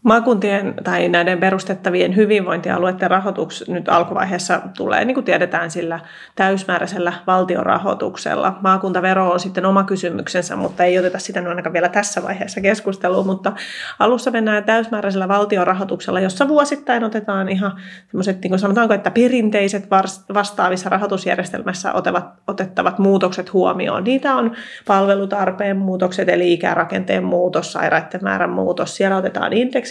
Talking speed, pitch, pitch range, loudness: 125 wpm, 195 Hz, 185-205 Hz, -18 LUFS